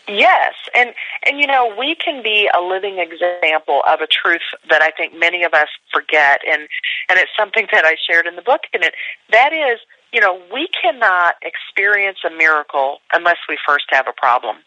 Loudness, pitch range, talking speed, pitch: -15 LUFS, 160-250 Hz, 195 wpm, 180 Hz